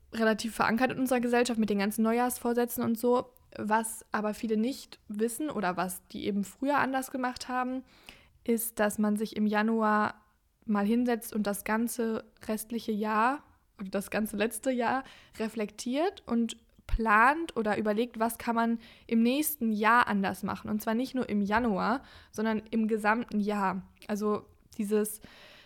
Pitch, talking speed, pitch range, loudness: 225 Hz, 155 wpm, 210-240 Hz, -30 LUFS